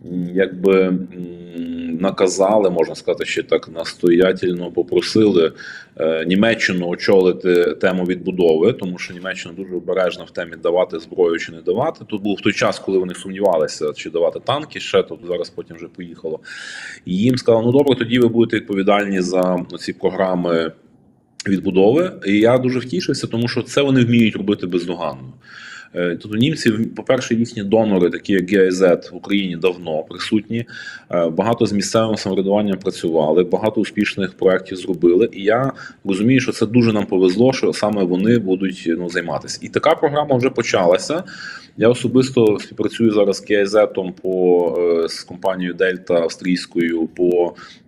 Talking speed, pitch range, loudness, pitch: 145 wpm, 90-120 Hz, -18 LUFS, 100 Hz